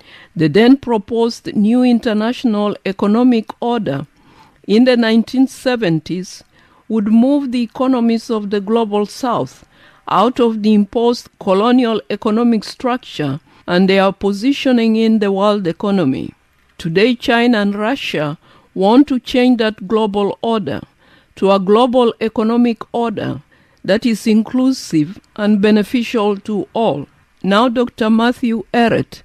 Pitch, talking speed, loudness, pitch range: 225 Hz, 120 wpm, -15 LUFS, 205-240 Hz